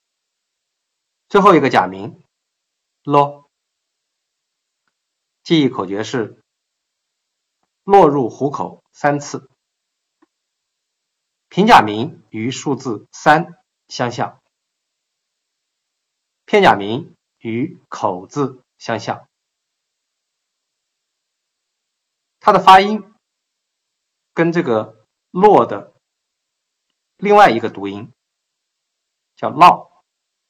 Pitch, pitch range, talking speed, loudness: 145 Hz, 115-180 Hz, 100 characters per minute, -15 LUFS